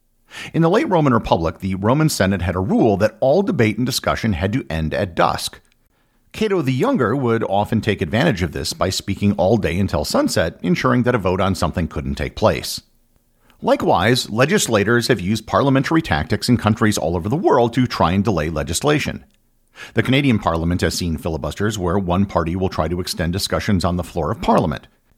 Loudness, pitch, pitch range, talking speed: -18 LUFS, 100 Hz, 90-115 Hz, 195 wpm